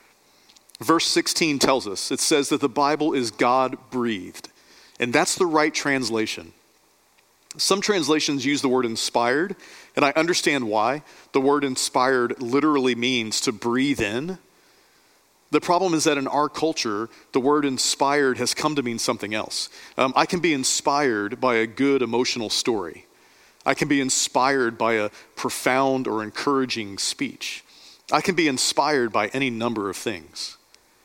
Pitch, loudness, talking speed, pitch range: 135 Hz, -22 LUFS, 155 wpm, 120-150 Hz